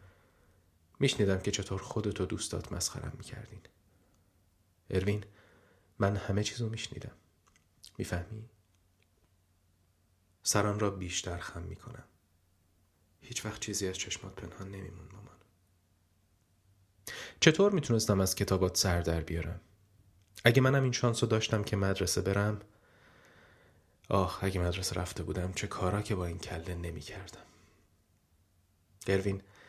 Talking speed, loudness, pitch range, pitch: 115 wpm, -32 LUFS, 90-105 Hz, 95 Hz